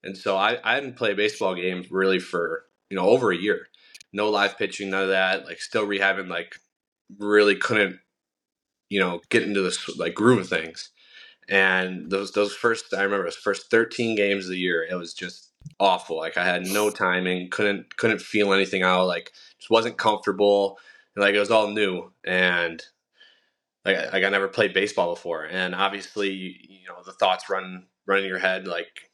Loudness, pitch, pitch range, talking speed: -23 LUFS, 95 Hz, 90-100 Hz, 195 wpm